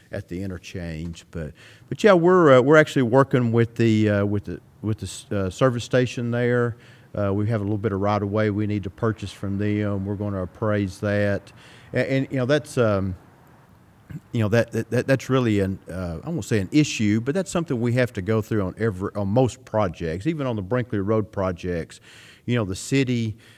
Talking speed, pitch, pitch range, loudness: 220 wpm, 110 Hz, 100-125 Hz, -23 LUFS